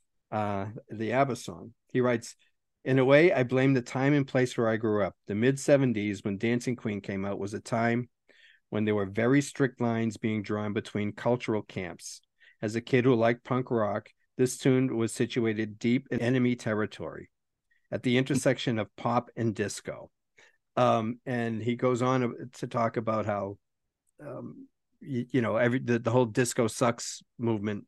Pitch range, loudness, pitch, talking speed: 110-125 Hz, -28 LUFS, 120 Hz, 180 wpm